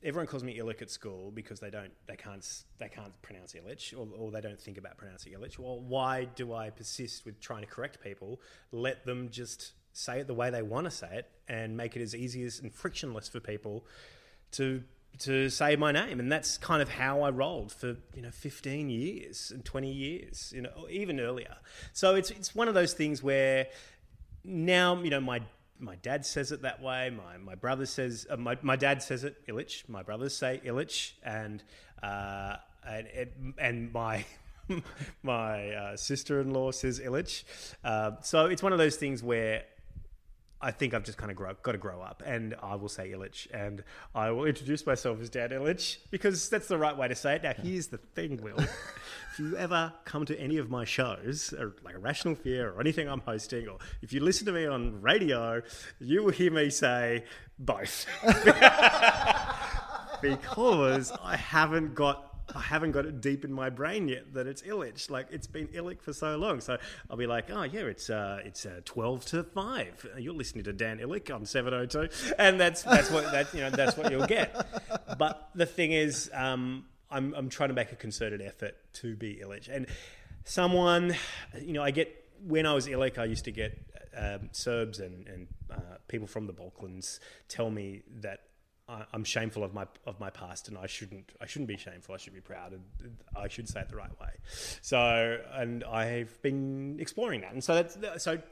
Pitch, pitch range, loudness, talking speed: 125 Hz, 110-145 Hz, -31 LUFS, 205 wpm